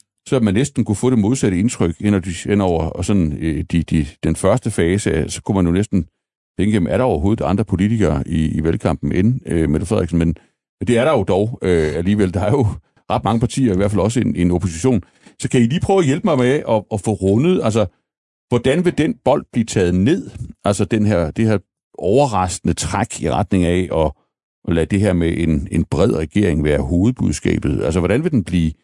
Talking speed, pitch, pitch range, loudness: 220 wpm, 100 Hz, 85-110 Hz, -17 LUFS